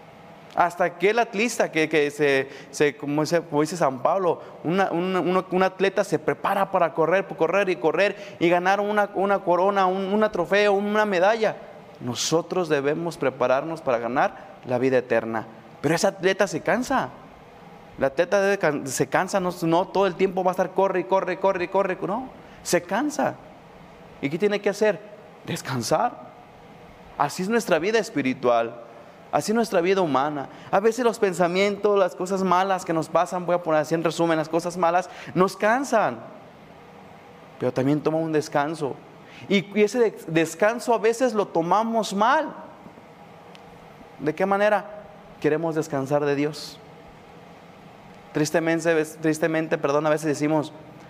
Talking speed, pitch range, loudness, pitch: 155 wpm, 155-200 Hz, -23 LUFS, 175 Hz